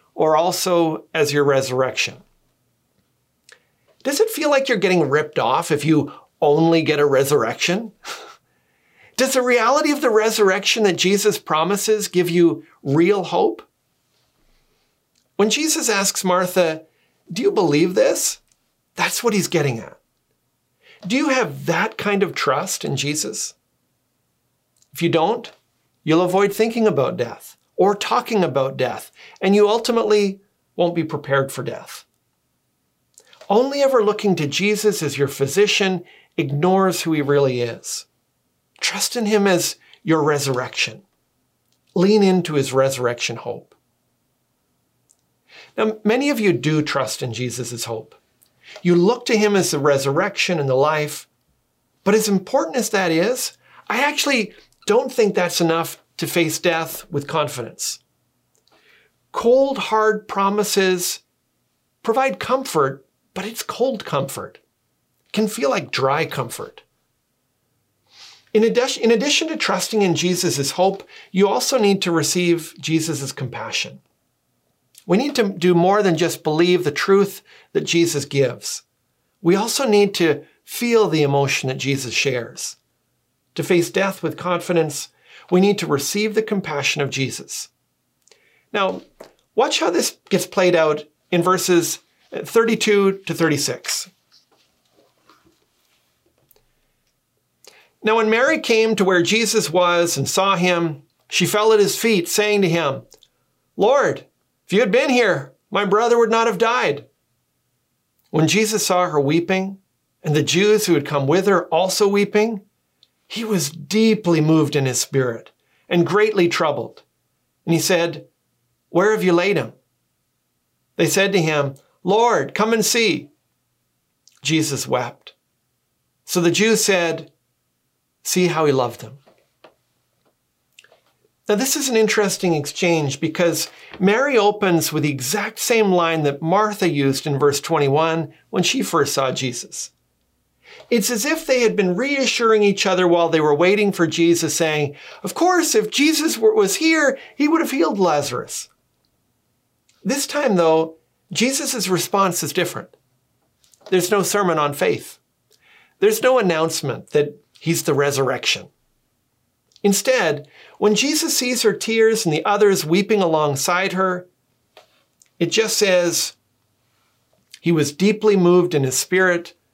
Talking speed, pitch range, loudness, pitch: 135 wpm, 150-215 Hz, -19 LUFS, 180 Hz